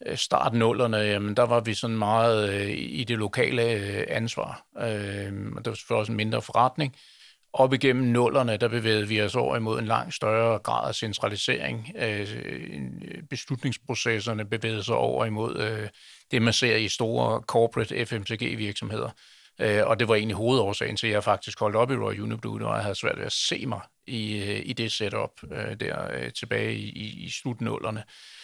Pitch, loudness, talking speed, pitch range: 115 Hz, -27 LUFS, 175 wpm, 105-120 Hz